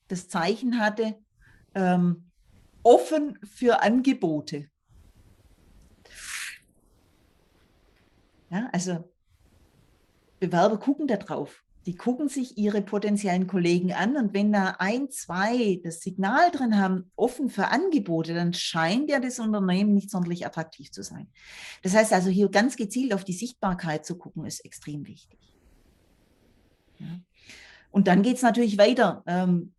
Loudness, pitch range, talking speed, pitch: -25 LUFS, 170-220 Hz, 130 wpm, 190 Hz